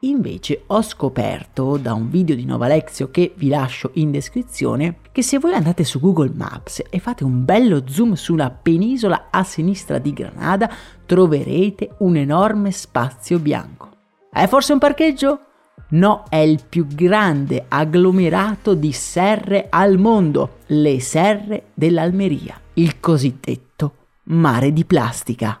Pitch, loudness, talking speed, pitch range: 170 Hz, -17 LUFS, 140 wpm, 145-200 Hz